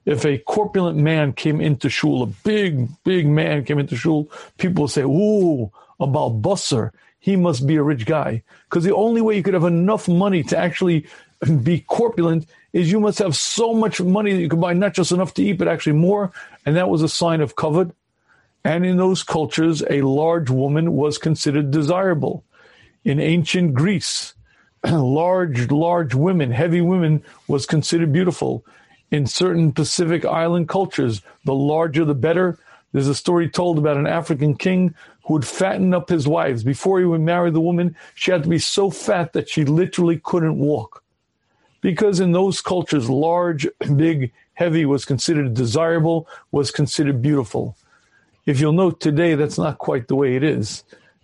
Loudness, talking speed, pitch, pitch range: -19 LUFS, 175 wpm, 165 Hz, 150-180 Hz